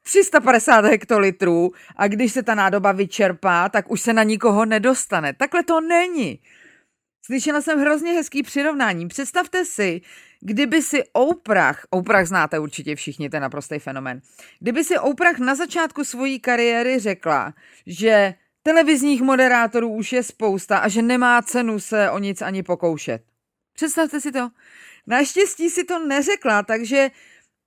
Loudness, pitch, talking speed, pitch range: -19 LUFS, 235 Hz, 140 wpm, 195-290 Hz